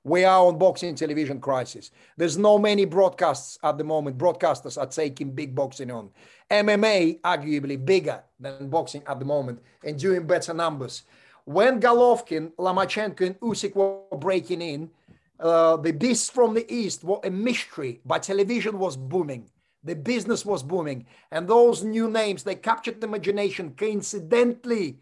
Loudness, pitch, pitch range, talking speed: -24 LUFS, 180 Hz, 150-210 Hz, 155 wpm